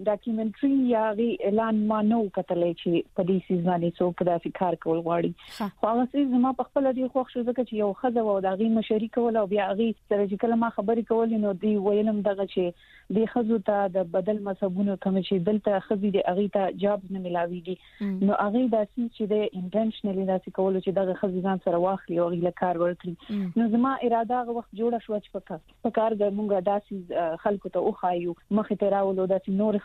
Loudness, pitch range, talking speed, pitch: -26 LUFS, 190-225 Hz, 205 wpm, 205 Hz